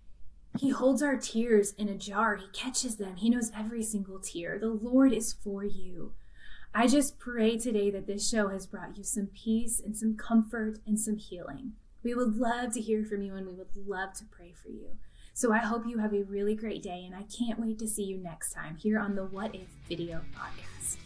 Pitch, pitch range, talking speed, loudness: 215 Hz, 195-230 Hz, 220 wpm, -31 LUFS